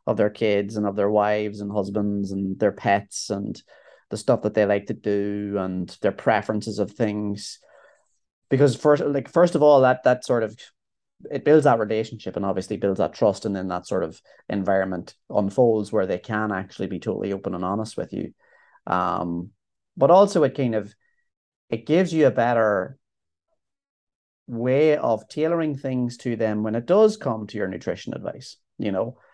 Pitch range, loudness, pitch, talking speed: 100-130 Hz, -23 LUFS, 105 Hz, 180 wpm